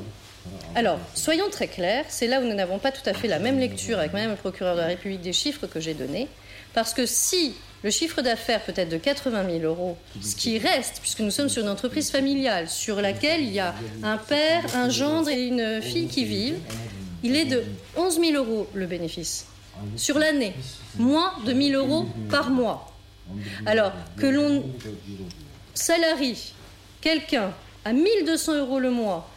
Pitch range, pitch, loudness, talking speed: 165-280 Hz, 225 Hz, -25 LUFS, 190 wpm